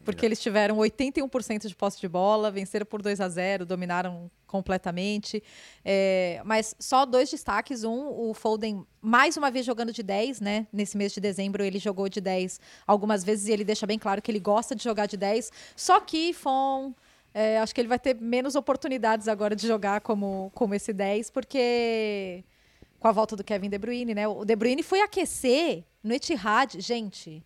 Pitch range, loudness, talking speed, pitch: 200-245 Hz, -27 LUFS, 190 wpm, 215 Hz